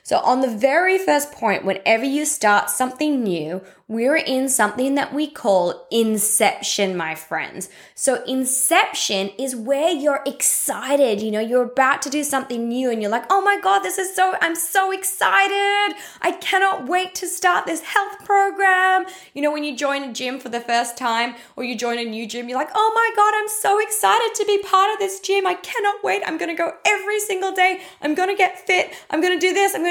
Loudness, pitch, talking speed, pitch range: -19 LUFS, 295 Hz, 215 wpm, 240-380 Hz